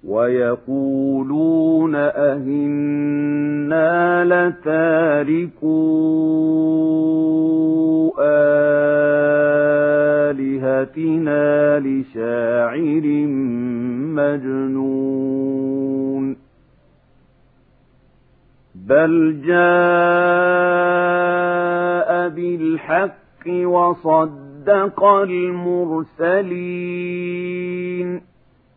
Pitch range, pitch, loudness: 145-180 Hz, 160 Hz, -17 LUFS